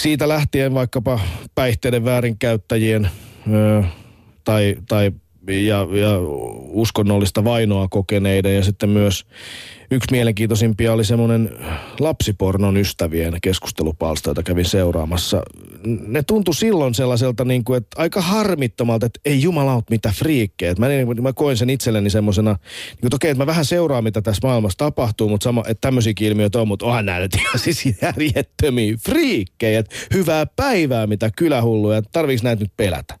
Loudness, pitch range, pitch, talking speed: -18 LUFS, 105-130 Hz, 115 Hz, 140 wpm